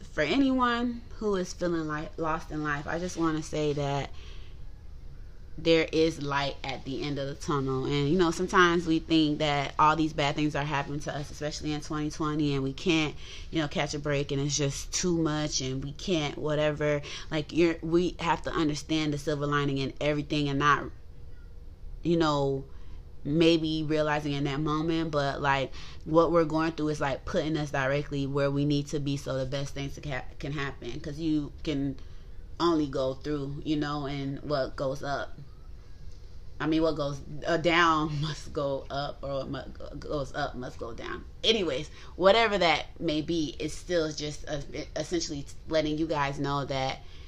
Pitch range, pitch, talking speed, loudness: 140-160 Hz, 150 Hz, 180 wpm, -29 LUFS